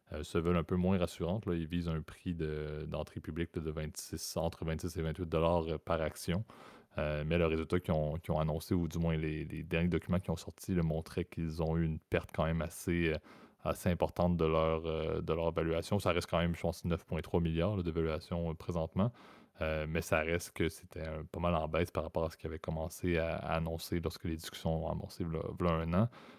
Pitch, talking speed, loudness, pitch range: 85 Hz, 230 wpm, -36 LUFS, 80-90 Hz